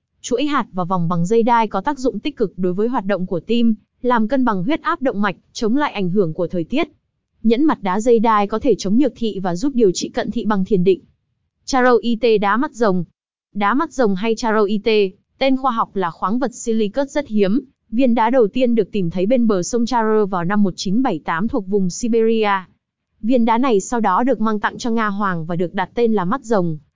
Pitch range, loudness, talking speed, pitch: 195-245 Hz, -18 LUFS, 230 wpm, 220 Hz